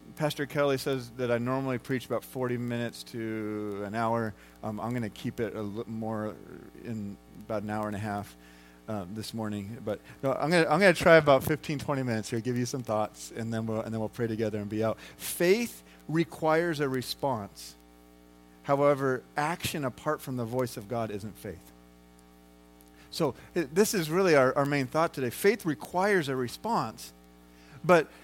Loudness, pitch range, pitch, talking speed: -29 LUFS, 105-140 Hz, 115 Hz, 185 wpm